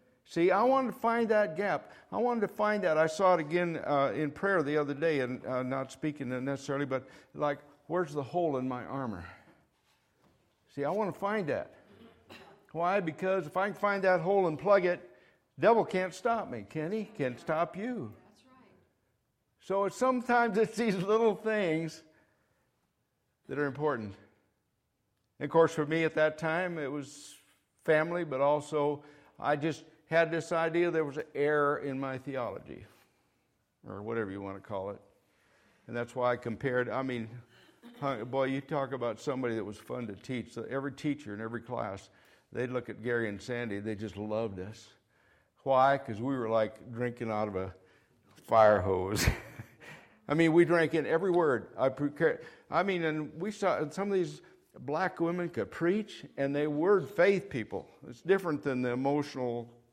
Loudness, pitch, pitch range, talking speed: -31 LUFS, 145 Hz, 125-175 Hz, 180 wpm